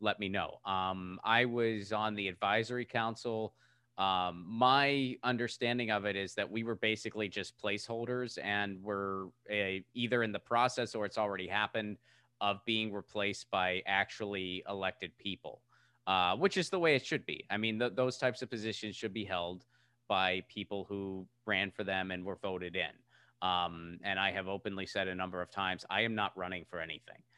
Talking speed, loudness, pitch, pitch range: 185 wpm, -35 LUFS, 105 Hz, 95-115 Hz